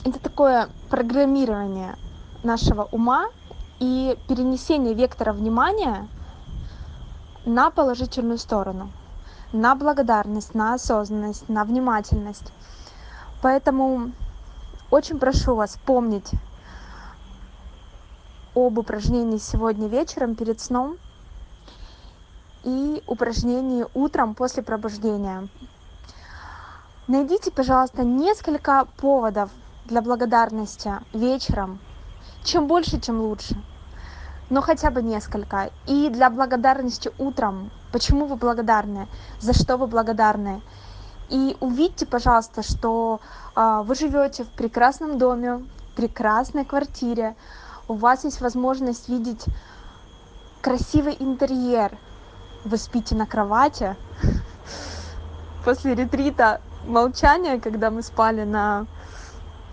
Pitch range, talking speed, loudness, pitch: 195-260 Hz, 90 wpm, -22 LUFS, 230 Hz